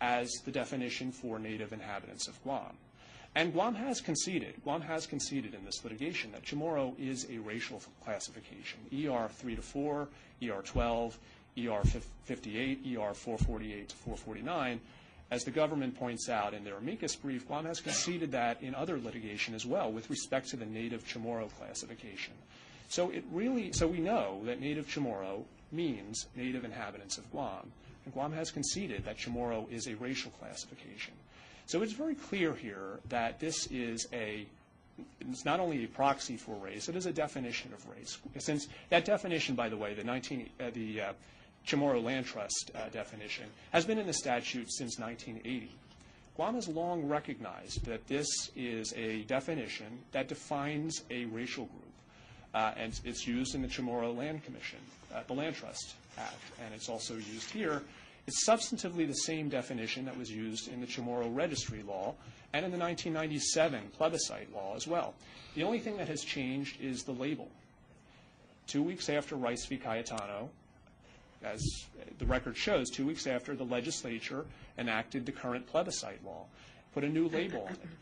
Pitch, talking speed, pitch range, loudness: 130 Hz, 170 wpm, 115-155 Hz, -37 LUFS